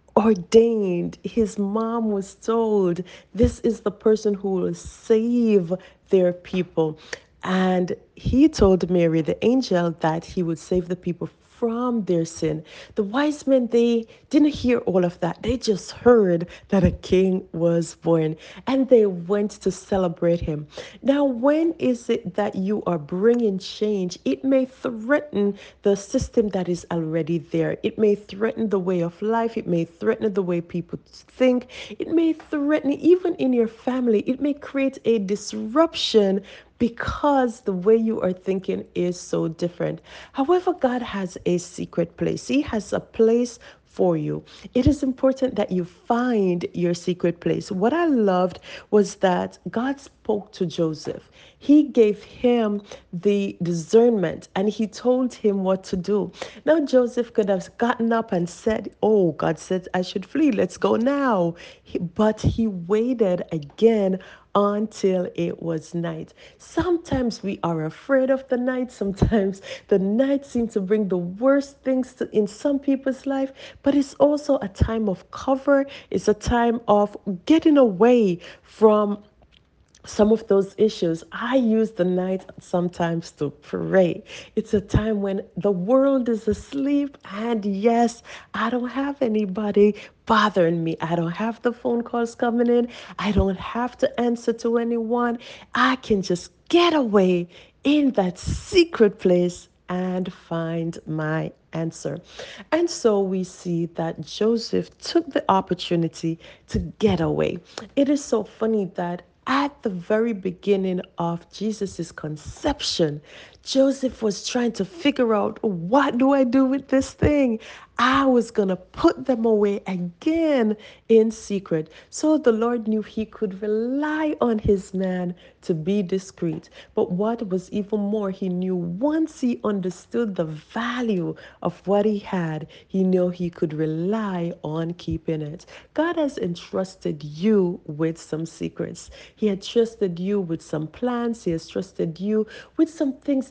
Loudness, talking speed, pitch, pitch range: -23 LUFS, 155 wpm, 210 Hz, 180-240 Hz